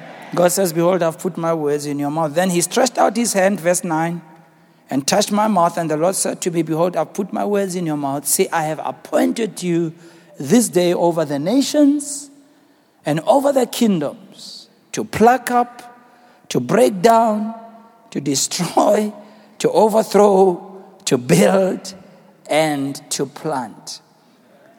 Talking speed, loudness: 155 wpm, -18 LUFS